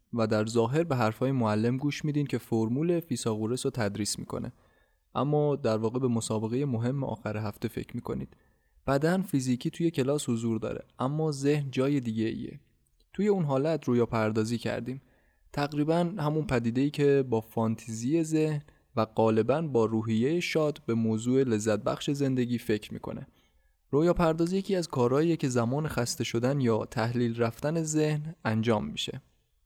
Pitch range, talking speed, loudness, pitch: 110-150 Hz, 155 wpm, -29 LUFS, 125 Hz